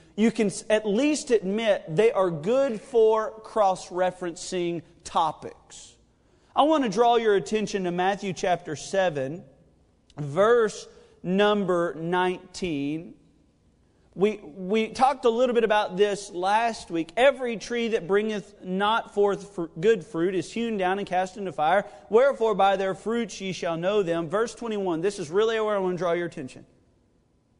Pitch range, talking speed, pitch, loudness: 180-225 Hz, 155 wpm, 200 Hz, -25 LUFS